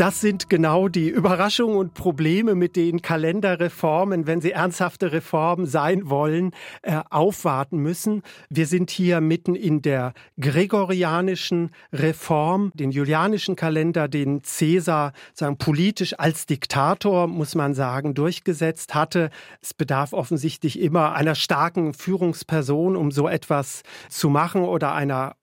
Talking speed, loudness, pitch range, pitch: 125 wpm, -22 LUFS, 155-185 Hz, 165 Hz